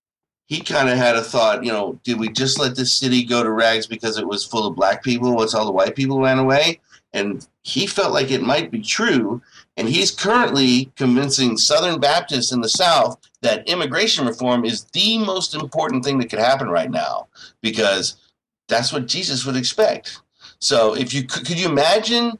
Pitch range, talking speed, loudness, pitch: 120-150 Hz, 195 wpm, -18 LUFS, 130 Hz